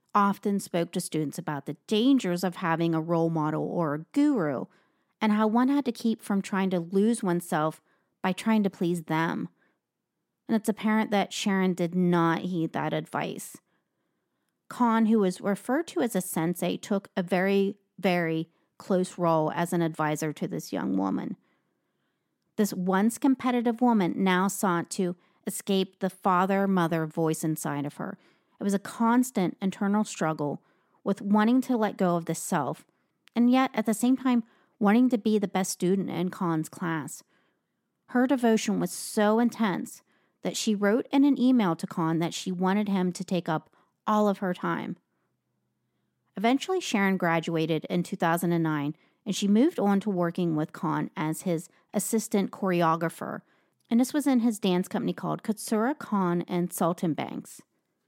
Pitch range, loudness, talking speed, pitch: 170-220 Hz, -27 LUFS, 165 wpm, 190 Hz